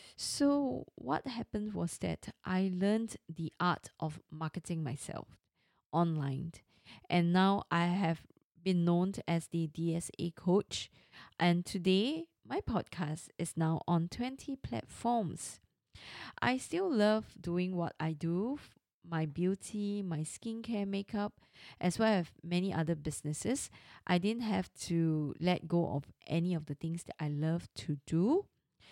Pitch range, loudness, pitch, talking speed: 165-205 Hz, -35 LUFS, 175 Hz, 135 wpm